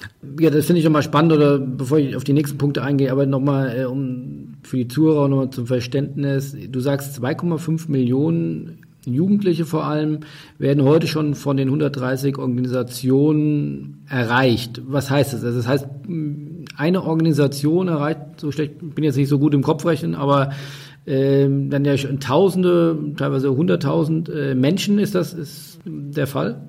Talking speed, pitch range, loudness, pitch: 165 wpm, 135-155 Hz, -19 LUFS, 145 Hz